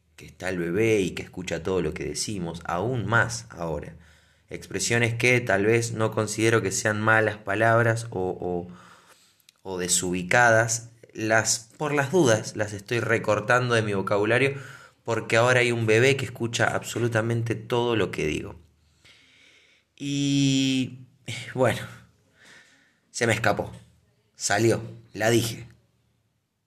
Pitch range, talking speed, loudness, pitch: 100-120 Hz, 130 wpm, -24 LUFS, 110 Hz